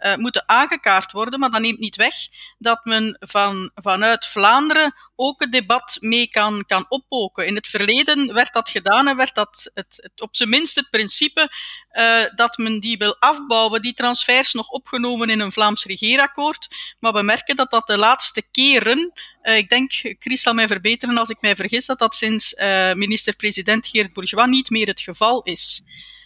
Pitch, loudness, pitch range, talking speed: 230 Hz, -16 LUFS, 210-255 Hz, 185 wpm